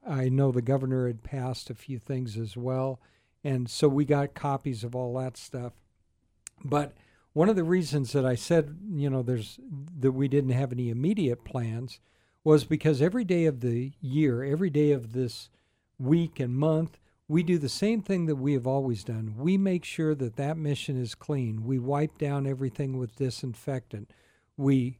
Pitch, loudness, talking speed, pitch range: 135 Hz, -28 LUFS, 185 wpm, 125-150 Hz